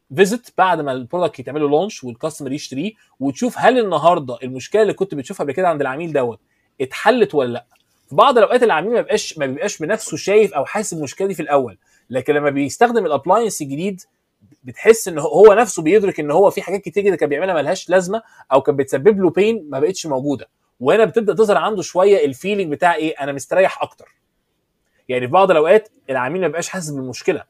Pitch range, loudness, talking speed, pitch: 140-210 Hz, -17 LUFS, 190 wpm, 175 Hz